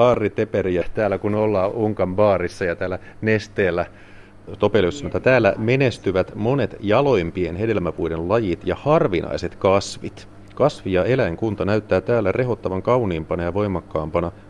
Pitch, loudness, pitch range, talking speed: 100 Hz, -21 LUFS, 90-110 Hz, 110 wpm